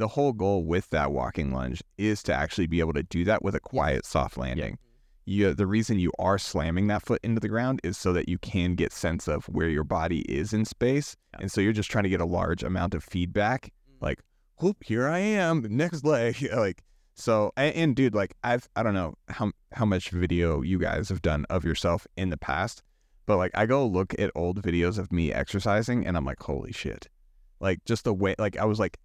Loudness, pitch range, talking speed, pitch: -28 LUFS, 85-110 Hz, 230 wpm, 95 Hz